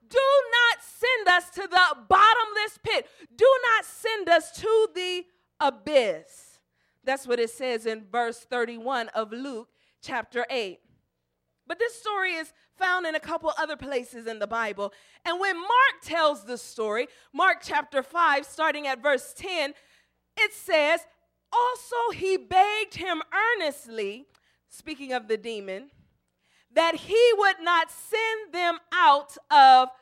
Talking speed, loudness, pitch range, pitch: 140 wpm, -24 LUFS, 265-390 Hz, 325 Hz